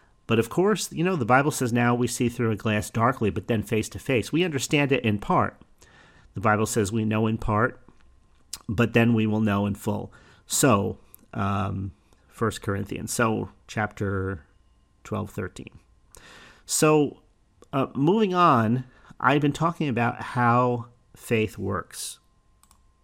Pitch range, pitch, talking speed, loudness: 105-125 Hz, 115 Hz, 150 wpm, -25 LUFS